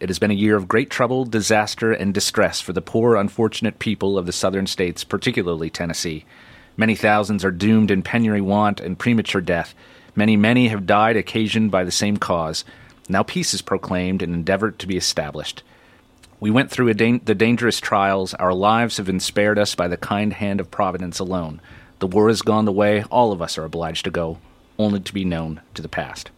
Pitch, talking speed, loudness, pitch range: 100 Hz, 205 wpm, -20 LUFS, 90-110 Hz